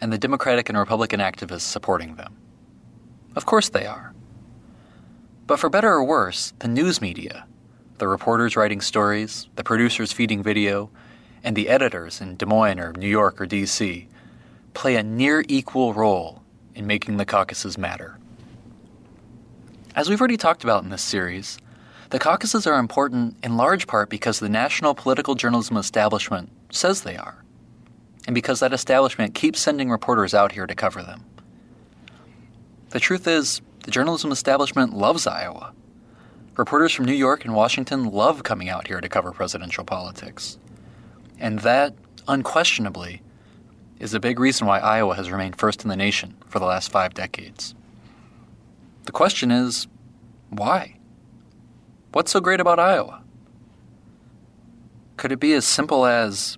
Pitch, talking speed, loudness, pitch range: 115 Hz, 150 wpm, -21 LUFS, 105-130 Hz